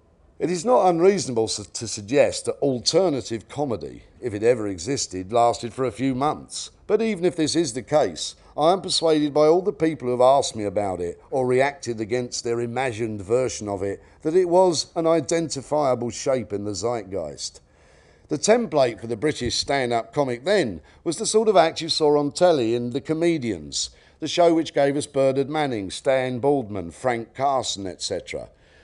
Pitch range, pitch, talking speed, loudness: 115-165 Hz, 135 Hz, 185 wpm, -23 LUFS